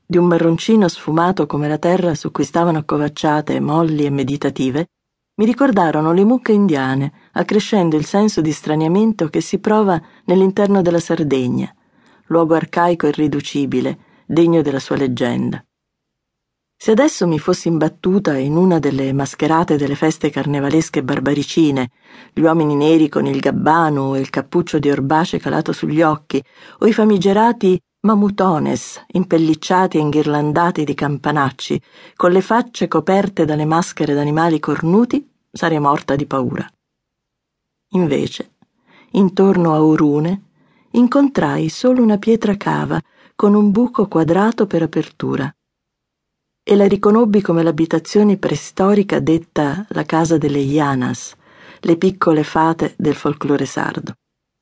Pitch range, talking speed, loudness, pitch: 150-195 Hz, 130 wpm, -16 LUFS, 165 Hz